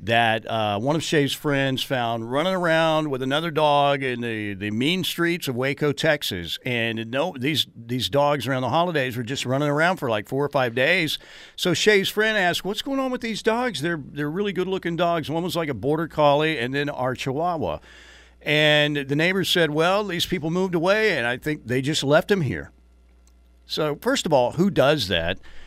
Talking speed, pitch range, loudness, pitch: 205 wpm, 125-170 Hz, -22 LUFS, 145 Hz